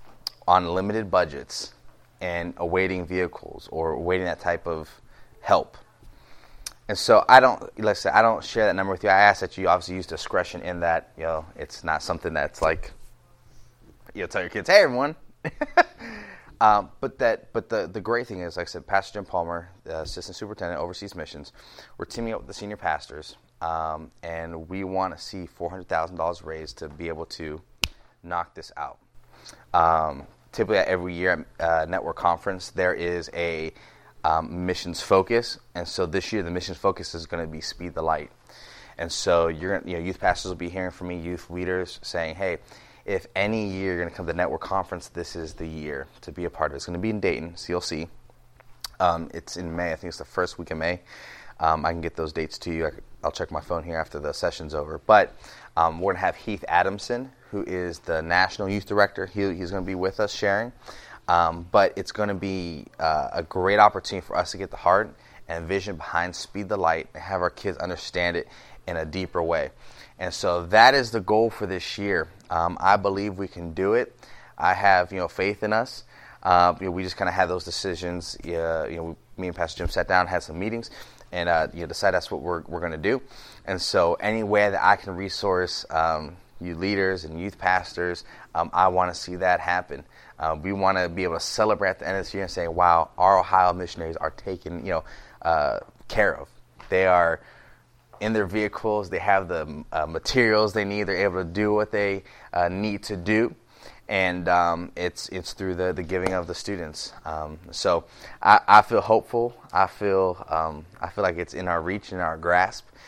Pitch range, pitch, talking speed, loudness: 85-100 Hz, 90 Hz, 215 wpm, -25 LUFS